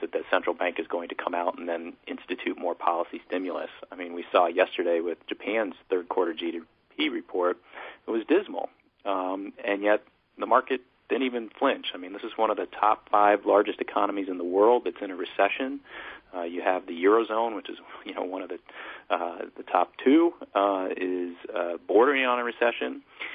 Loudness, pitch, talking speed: -27 LUFS, 120 Hz, 195 wpm